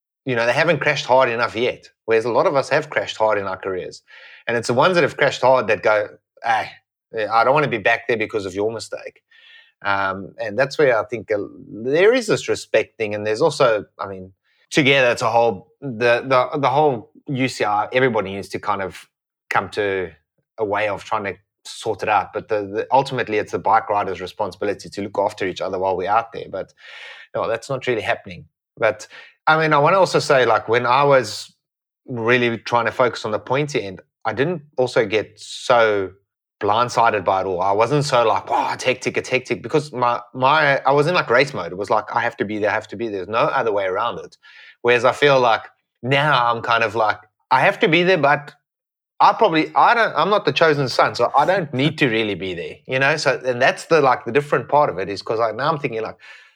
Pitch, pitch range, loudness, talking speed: 130 Hz, 115-160 Hz, -19 LUFS, 235 wpm